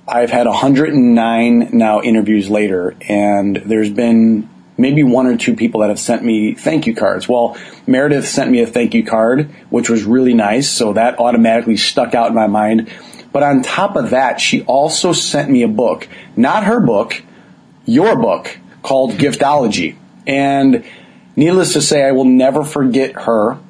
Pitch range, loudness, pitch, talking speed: 110-140 Hz, -13 LUFS, 120 Hz, 170 wpm